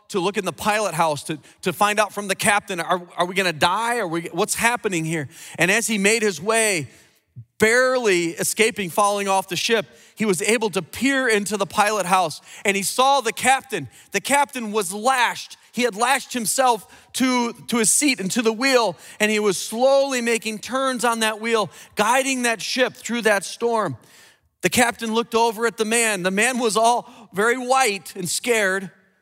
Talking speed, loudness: 195 wpm, -20 LUFS